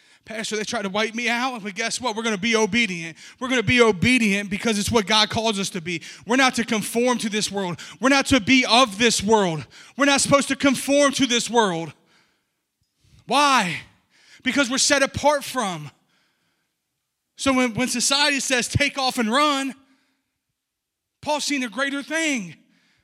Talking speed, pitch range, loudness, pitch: 175 wpm, 215-270 Hz, -20 LUFS, 240 Hz